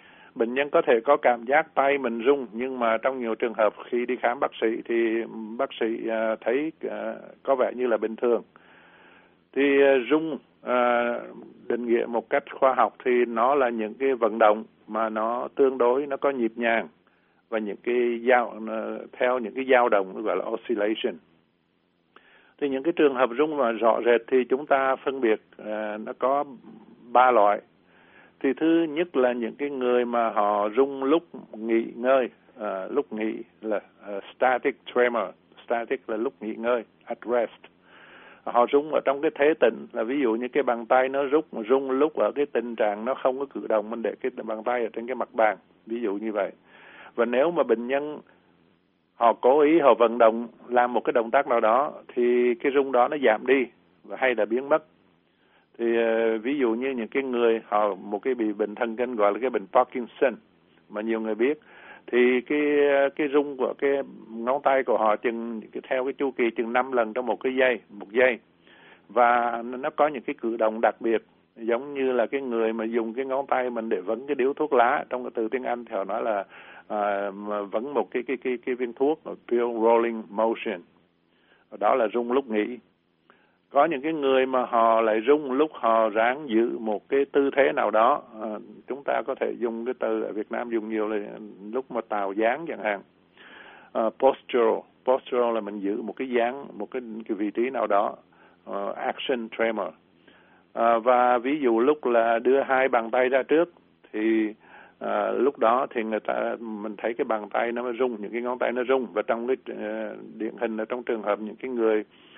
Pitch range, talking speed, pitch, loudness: 110-135 Hz, 205 wpm, 120 Hz, -25 LUFS